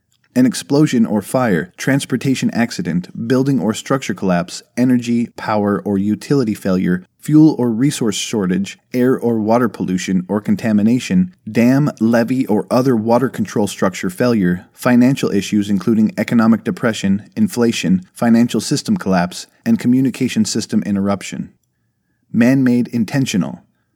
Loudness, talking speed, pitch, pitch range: -16 LUFS, 125 wpm, 120 Hz, 105-135 Hz